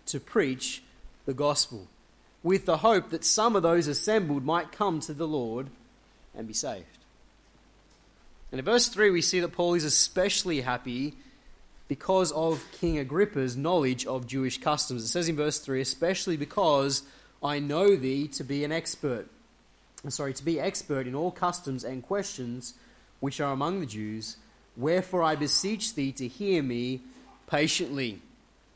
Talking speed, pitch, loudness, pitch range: 160 wpm, 150 Hz, -28 LUFS, 135-180 Hz